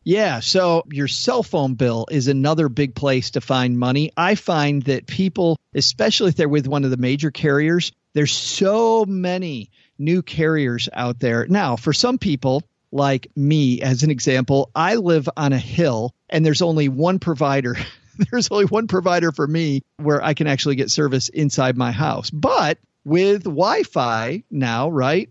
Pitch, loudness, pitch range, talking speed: 150 Hz, -19 LUFS, 135-175 Hz, 175 wpm